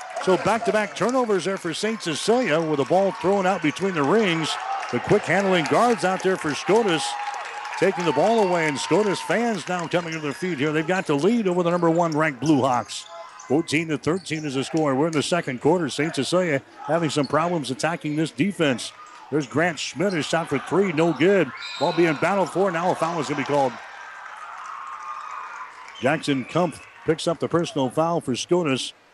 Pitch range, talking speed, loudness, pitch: 150-185 Hz, 200 wpm, -23 LUFS, 165 Hz